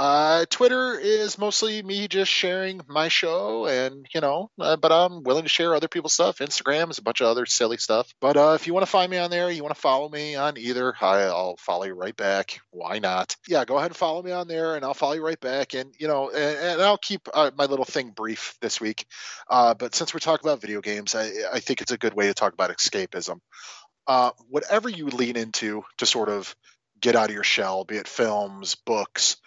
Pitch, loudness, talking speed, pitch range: 150 Hz, -24 LUFS, 240 wpm, 115-175 Hz